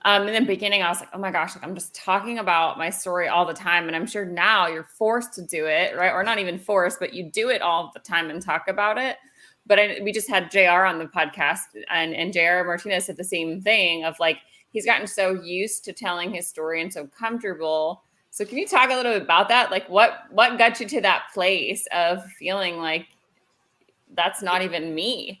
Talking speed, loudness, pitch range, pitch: 235 wpm, -22 LUFS, 170-205 Hz, 185 Hz